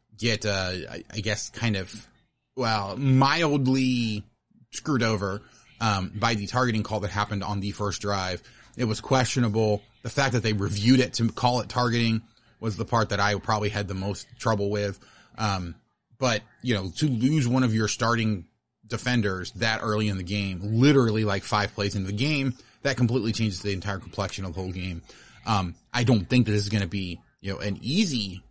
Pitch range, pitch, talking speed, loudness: 100-120 Hz, 110 Hz, 195 wpm, -26 LUFS